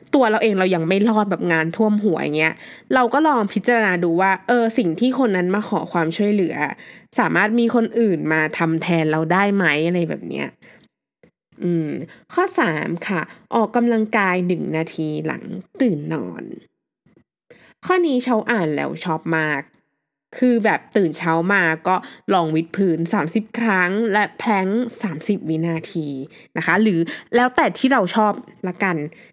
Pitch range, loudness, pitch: 165-225 Hz, -19 LUFS, 195 Hz